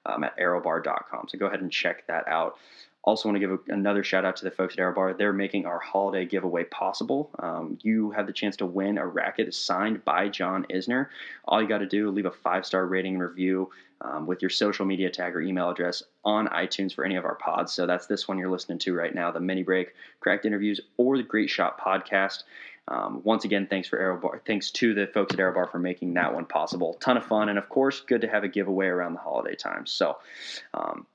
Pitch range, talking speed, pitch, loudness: 95-105 Hz, 245 wpm, 95 Hz, -27 LUFS